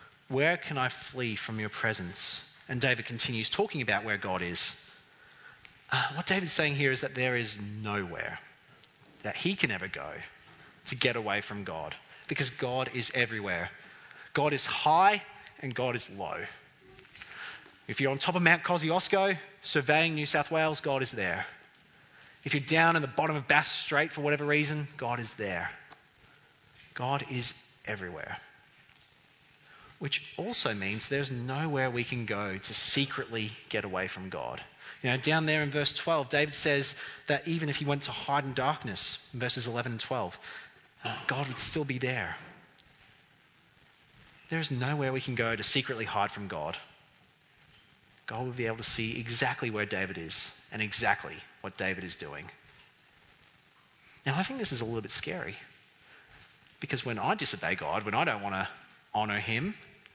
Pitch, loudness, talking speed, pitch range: 130 Hz, -31 LUFS, 170 wpm, 115-150 Hz